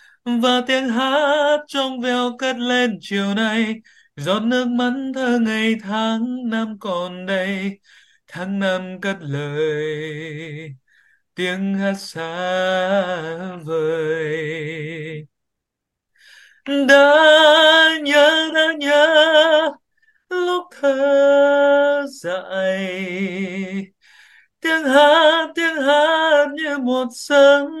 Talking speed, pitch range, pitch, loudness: 85 wpm, 185-290 Hz, 245 Hz, -17 LUFS